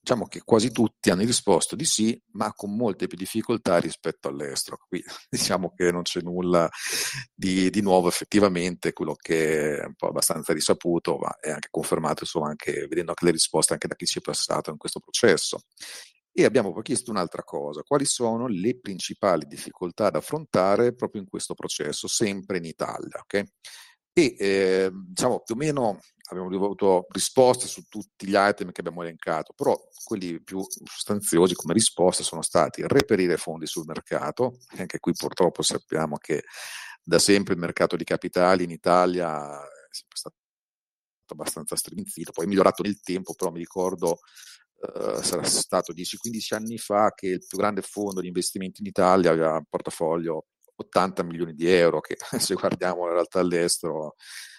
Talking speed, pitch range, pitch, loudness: 170 wpm, 85-105 Hz, 95 Hz, -25 LUFS